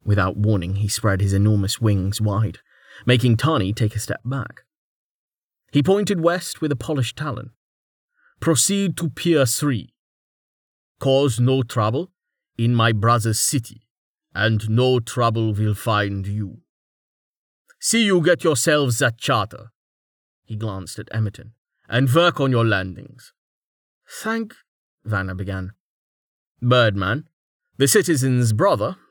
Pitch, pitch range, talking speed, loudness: 115 Hz, 105-140 Hz, 125 wpm, -20 LUFS